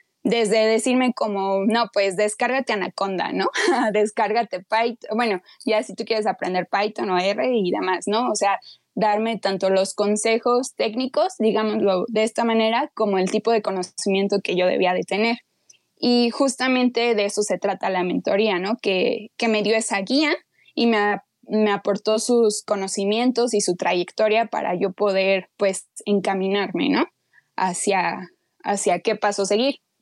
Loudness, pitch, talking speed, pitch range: -21 LUFS, 210 Hz, 160 wpm, 195-230 Hz